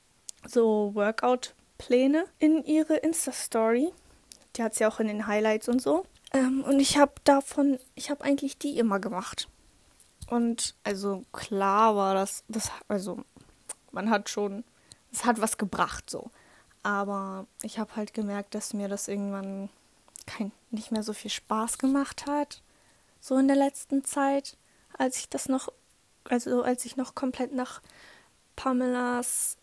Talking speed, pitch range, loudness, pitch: 150 wpm, 210-270 Hz, -28 LUFS, 240 Hz